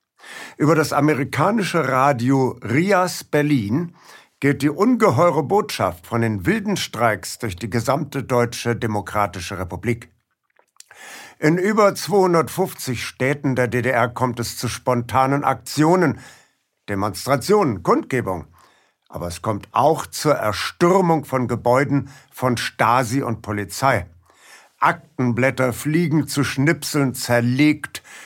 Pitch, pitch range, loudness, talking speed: 135 Hz, 120-160 Hz, -20 LUFS, 105 wpm